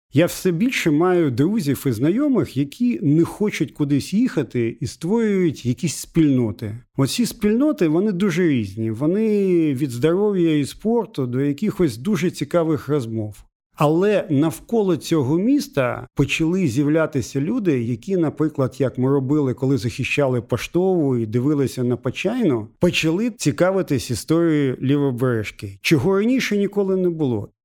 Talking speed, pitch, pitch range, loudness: 130 wpm, 150 Hz, 130-180 Hz, -20 LUFS